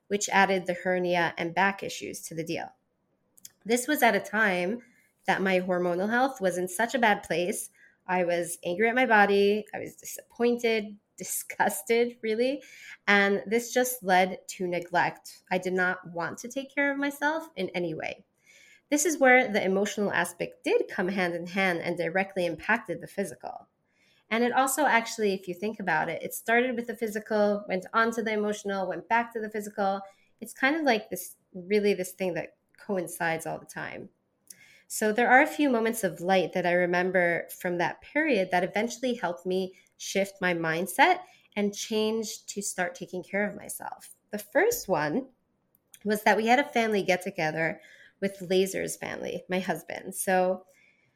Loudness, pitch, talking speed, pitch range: -27 LUFS, 200 Hz, 180 wpm, 180-230 Hz